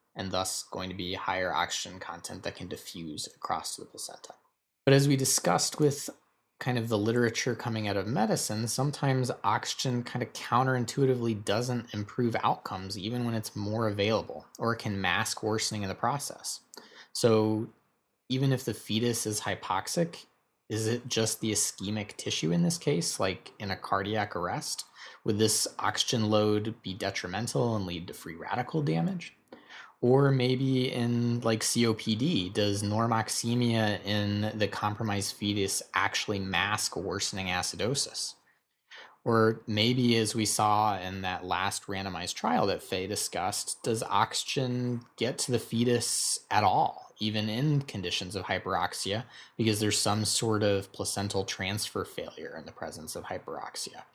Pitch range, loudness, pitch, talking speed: 105-120 Hz, -30 LUFS, 110 Hz, 150 wpm